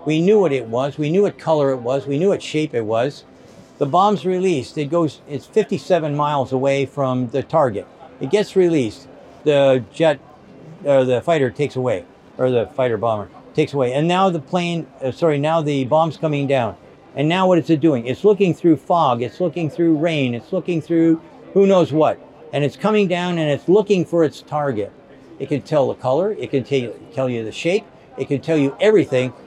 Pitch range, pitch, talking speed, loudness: 135-170 Hz, 150 Hz, 210 wpm, -19 LUFS